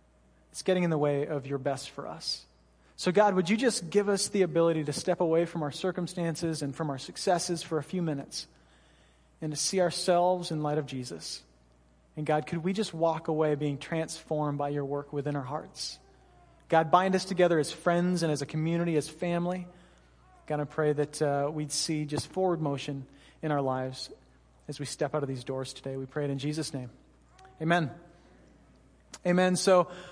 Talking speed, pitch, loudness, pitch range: 195 wpm, 150 Hz, -30 LUFS, 140-175 Hz